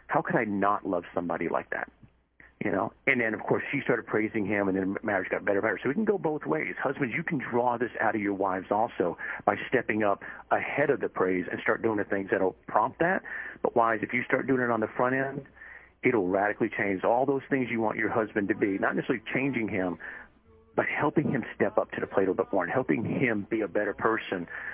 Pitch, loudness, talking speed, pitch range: 110 Hz, -28 LUFS, 245 wpm, 100-130 Hz